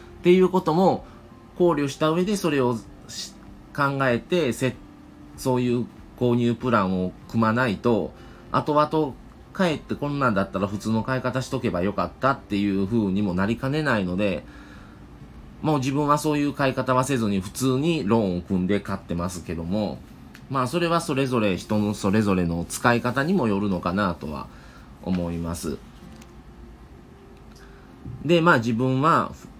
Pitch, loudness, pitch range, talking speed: 120 Hz, -24 LUFS, 100-135 Hz, 300 characters per minute